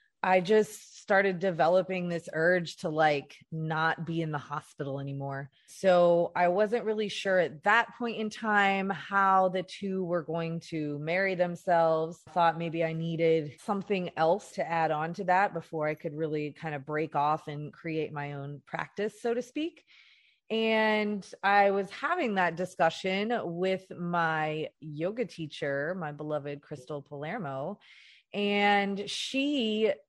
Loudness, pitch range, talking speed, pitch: -29 LUFS, 155-200 Hz, 150 wpm, 175 Hz